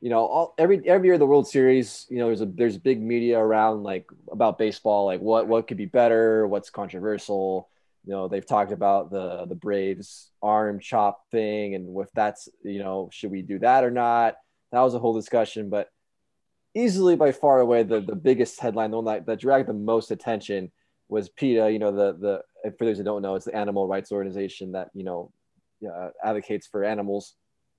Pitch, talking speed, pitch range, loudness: 110 Hz, 205 wpm, 100-120 Hz, -24 LUFS